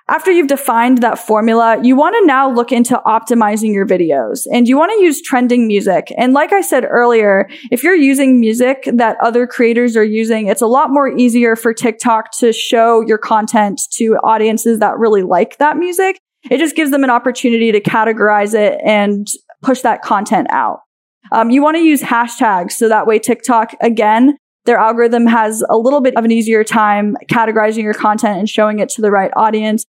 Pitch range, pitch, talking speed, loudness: 220-260 Hz, 230 Hz, 195 wpm, -12 LUFS